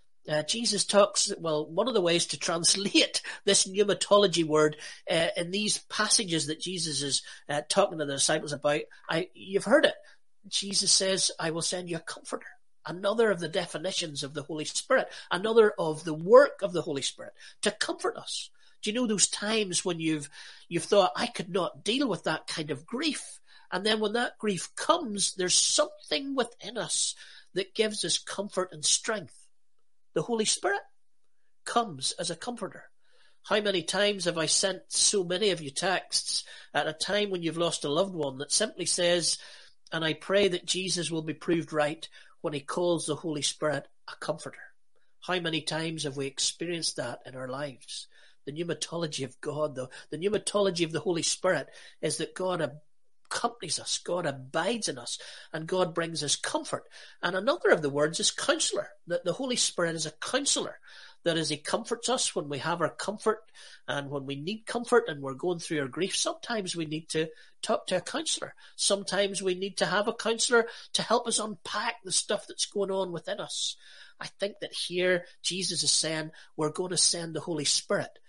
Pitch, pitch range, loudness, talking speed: 180 Hz, 155-205 Hz, -28 LUFS, 190 wpm